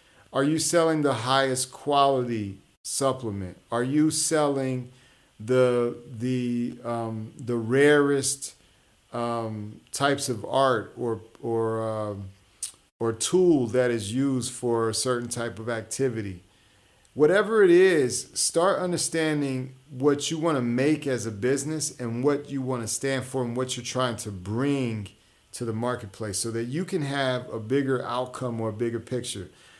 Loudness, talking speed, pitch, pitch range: -26 LUFS, 150 wpm, 125 Hz, 115-140 Hz